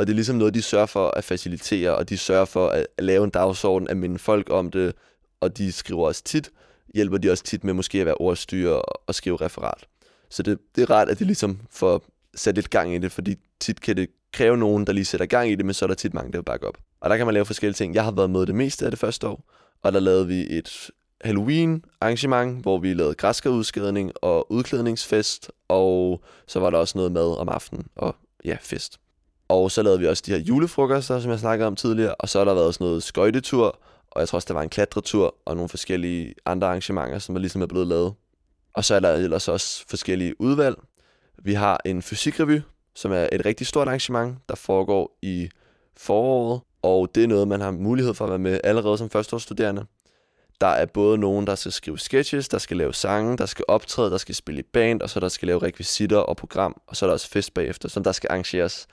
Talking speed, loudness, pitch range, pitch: 240 wpm, -23 LUFS, 95-115 Hz, 100 Hz